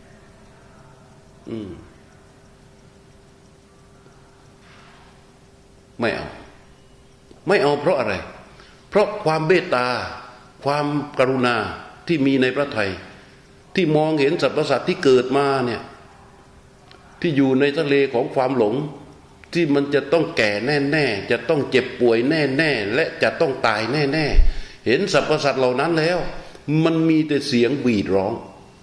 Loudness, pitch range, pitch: -20 LUFS, 125-155 Hz, 140 Hz